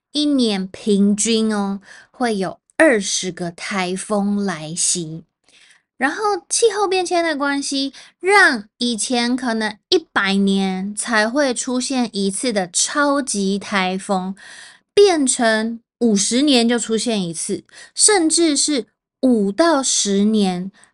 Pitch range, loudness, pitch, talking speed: 195-275 Hz, -18 LUFS, 225 Hz, 170 characters per minute